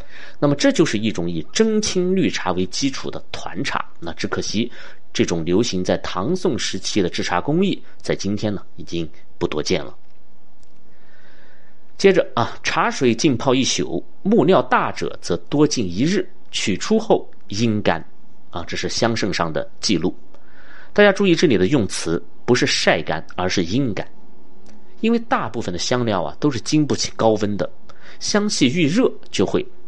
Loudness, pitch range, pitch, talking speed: -20 LUFS, 95-150 Hz, 115 Hz, 235 characters per minute